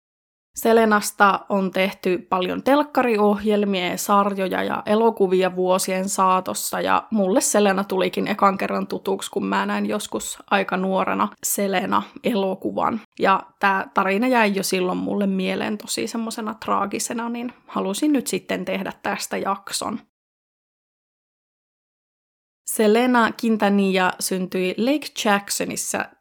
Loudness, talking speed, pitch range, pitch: -21 LUFS, 110 wpm, 185-220 Hz, 200 Hz